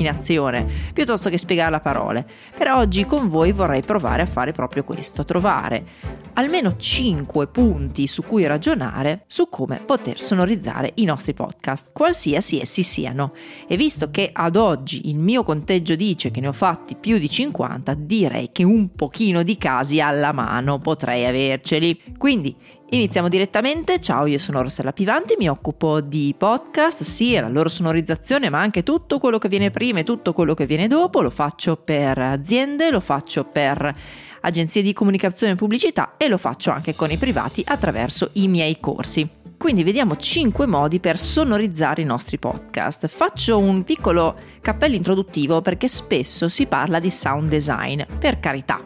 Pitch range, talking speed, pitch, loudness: 150-215 Hz, 165 wpm, 170 Hz, -20 LUFS